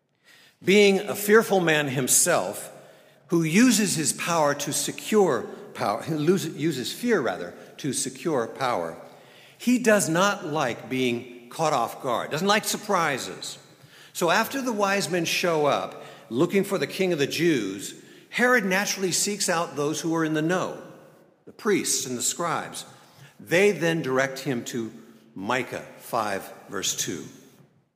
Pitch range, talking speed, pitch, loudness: 145-200 Hz, 145 wpm, 170 Hz, -24 LUFS